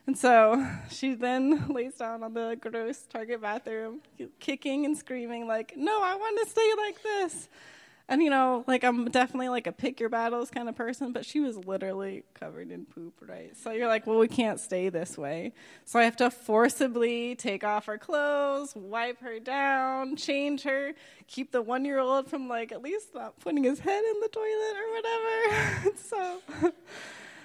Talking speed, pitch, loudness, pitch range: 190 wpm, 255 Hz, -29 LUFS, 230-300 Hz